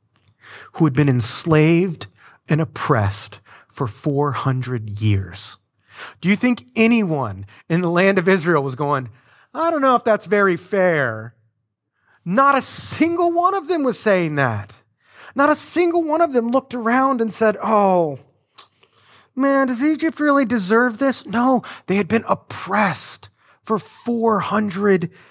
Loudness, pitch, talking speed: -19 LUFS, 190 Hz, 145 wpm